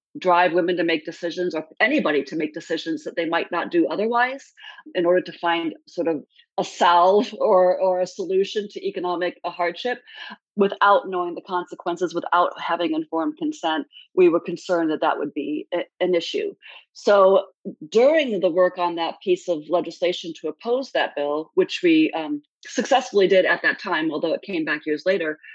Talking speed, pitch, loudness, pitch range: 180 wpm, 180 Hz, -22 LUFS, 170-250 Hz